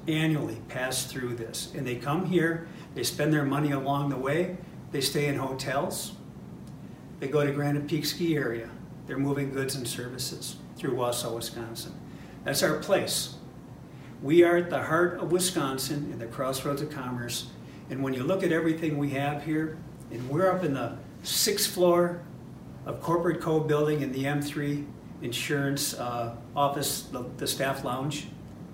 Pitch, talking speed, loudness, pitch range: 145 Hz, 165 wpm, -29 LUFS, 130-160 Hz